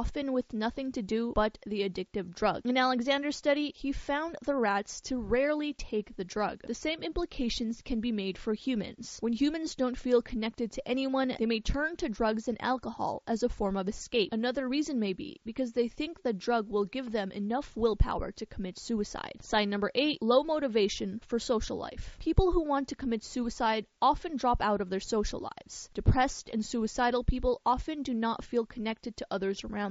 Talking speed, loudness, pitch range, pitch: 195 wpm, -32 LUFS, 220-265 Hz, 240 Hz